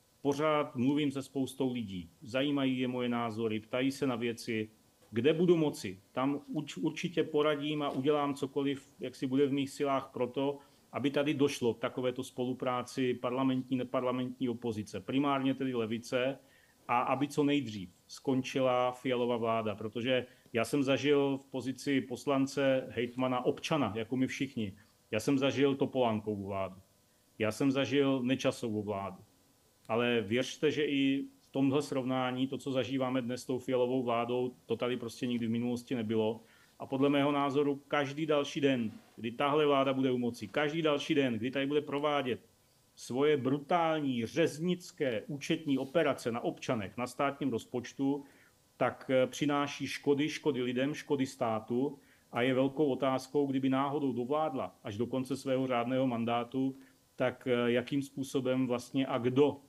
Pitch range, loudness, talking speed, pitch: 120-140 Hz, -33 LUFS, 150 wpm, 130 Hz